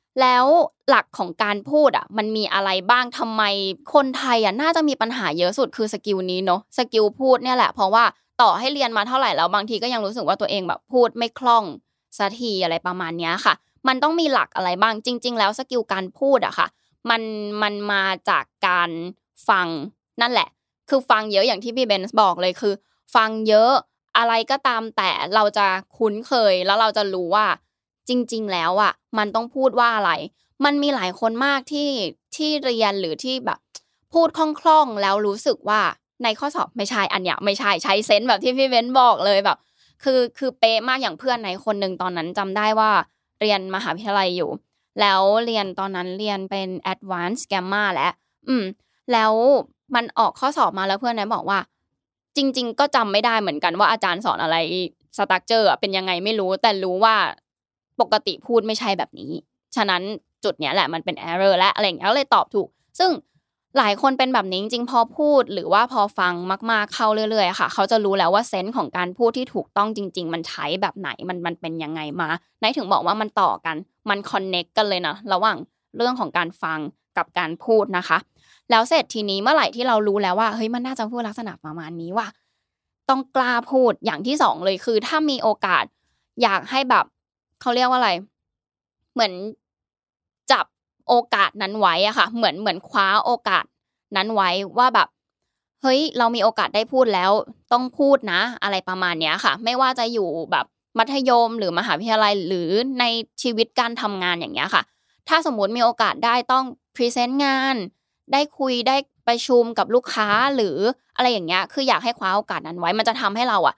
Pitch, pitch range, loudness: 220 Hz, 195-250 Hz, -20 LUFS